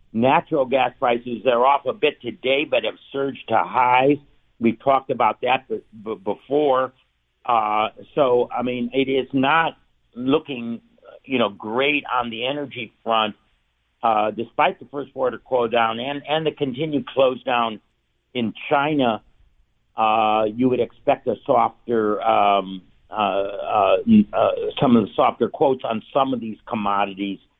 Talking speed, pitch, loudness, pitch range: 150 wpm, 120 Hz, -21 LUFS, 110-140 Hz